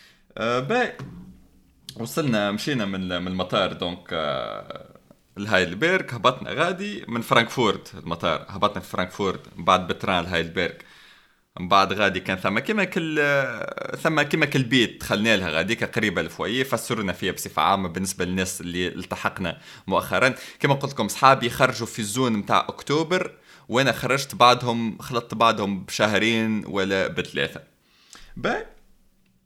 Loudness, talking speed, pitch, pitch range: -23 LUFS, 120 wpm, 110 Hz, 95-130 Hz